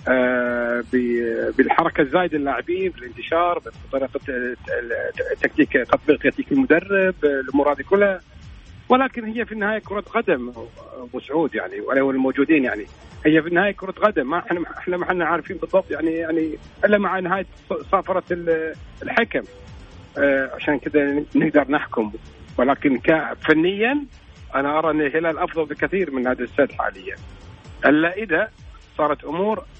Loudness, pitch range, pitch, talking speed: -21 LUFS, 135-190 Hz, 160 Hz, 125 wpm